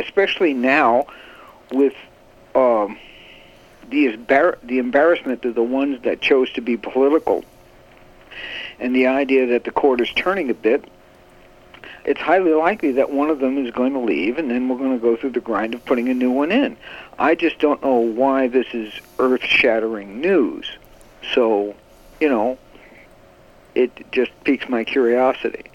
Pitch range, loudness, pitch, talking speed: 115-135 Hz, -19 LUFS, 130 Hz, 160 wpm